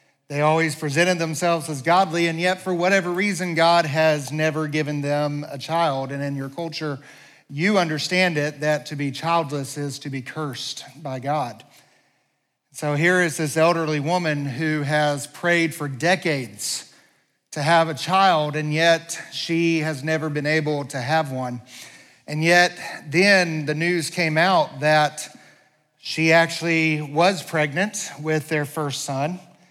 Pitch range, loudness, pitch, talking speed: 145-170 Hz, -21 LUFS, 155 Hz, 155 wpm